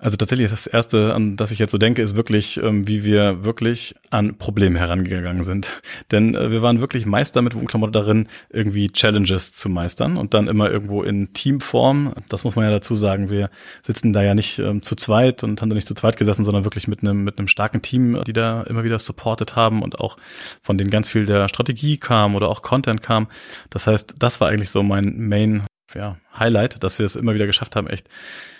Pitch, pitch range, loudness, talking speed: 105 Hz, 100-115 Hz, -19 LUFS, 215 wpm